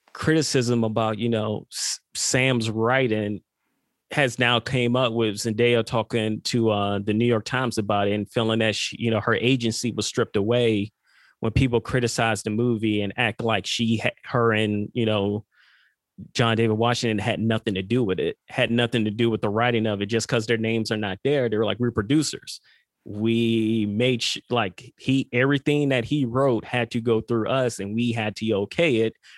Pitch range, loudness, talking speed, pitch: 110-120 Hz, -23 LUFS, 195 wpm, 115 Hz